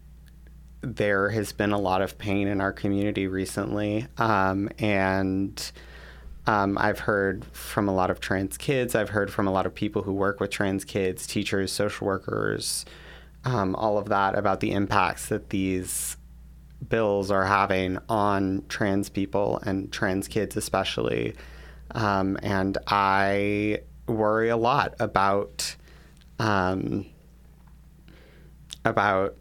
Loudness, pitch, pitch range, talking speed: -26 LUFS, 100 Hz, 95-105 Hz, 135 wpm